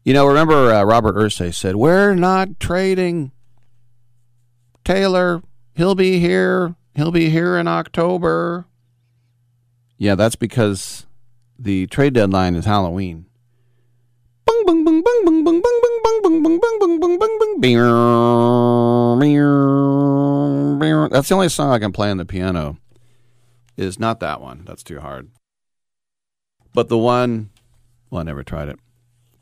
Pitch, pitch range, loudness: 120 Hz, 120-170 Hz, -16 LUFS